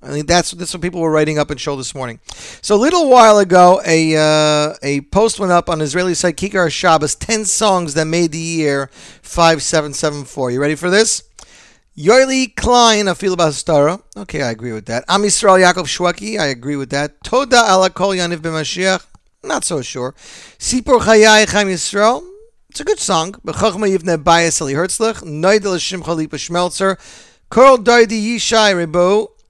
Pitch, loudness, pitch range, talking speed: 180 Hz, -14 LUFS, 155-210 Hz, 175 wpm